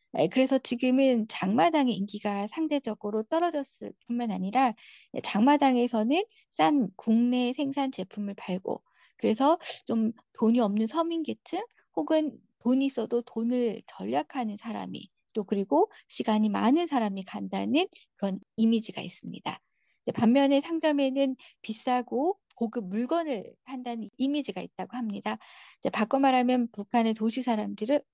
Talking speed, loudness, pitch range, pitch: 300 characters per minute, -28 LUFS, 220-275 Hz, 245 Hz